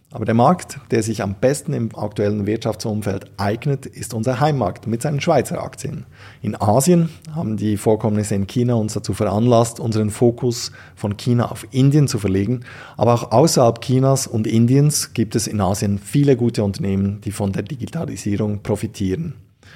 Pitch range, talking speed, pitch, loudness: 105-130 Hz, 165 wpm, 115 Hz, -19 LUFS